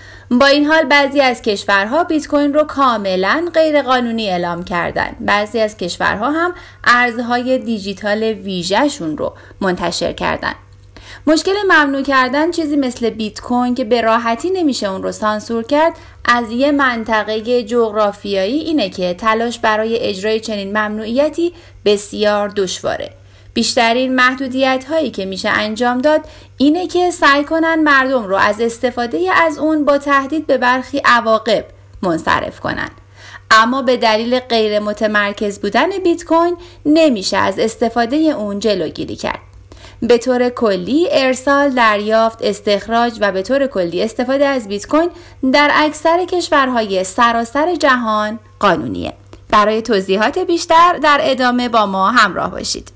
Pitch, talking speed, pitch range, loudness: 240 Hz, 135 wpm, 210-290 Hz, -15 LUFS